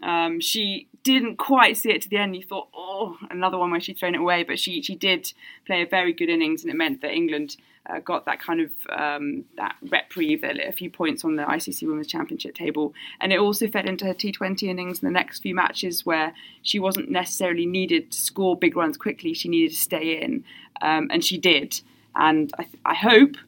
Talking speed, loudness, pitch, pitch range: 225 wpm, -23 LUFS, 190 Hz, 170-275 Hz